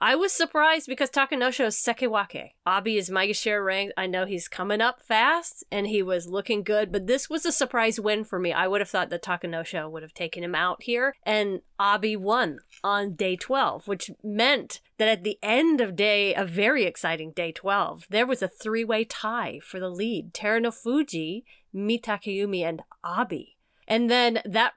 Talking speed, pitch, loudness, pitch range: 185 wpm, 210 Hz, -25 LUFS, 190-235 Hz